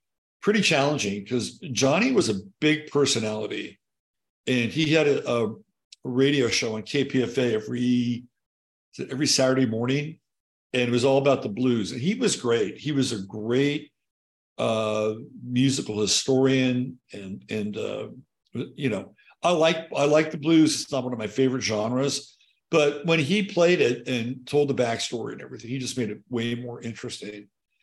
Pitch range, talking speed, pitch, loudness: 115-145 Hz, 160 wpm, 130 Hz, -24 LUFS